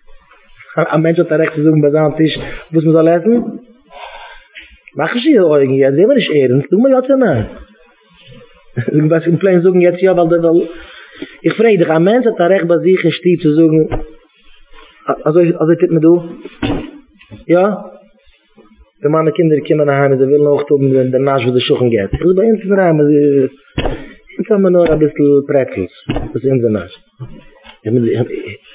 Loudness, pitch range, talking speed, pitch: -12 LUFS, 145-185 Hz, 150 wpm, 165 Hz